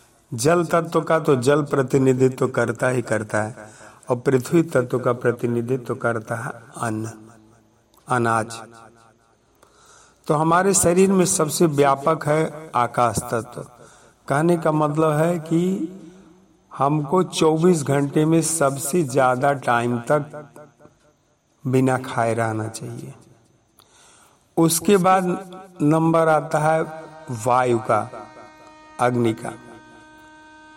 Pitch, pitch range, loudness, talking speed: 145 Hz, 120-165 Hz, -20 LUFS, 110 wpm